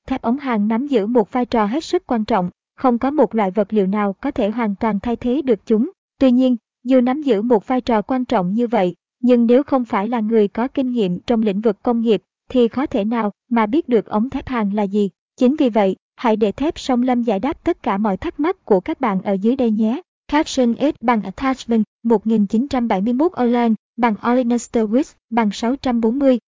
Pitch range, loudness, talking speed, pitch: 220-255 Hz, -18 LUFS, 220 wpm, 235 Hz